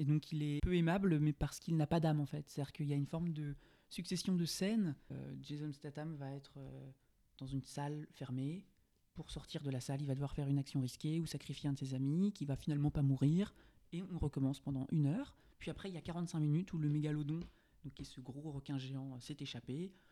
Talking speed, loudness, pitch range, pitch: 245 wpm, -40 LUFS, 140-165 Hz, 150 Hz